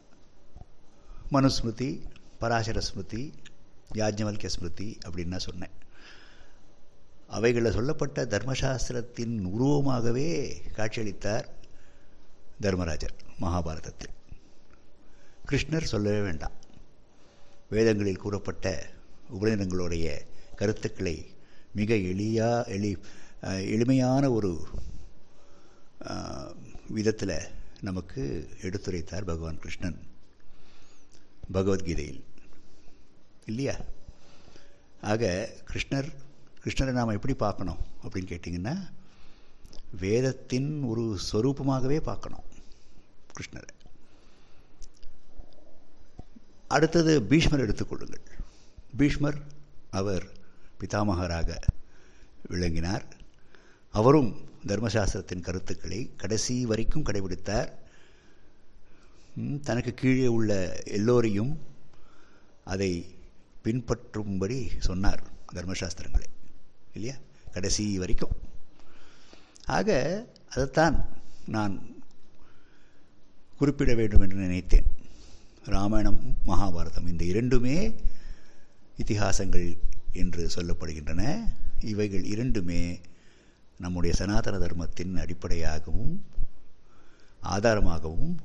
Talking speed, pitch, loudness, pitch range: 60 wpm, 100 Hz, -30 LUFS, 90-115 Hz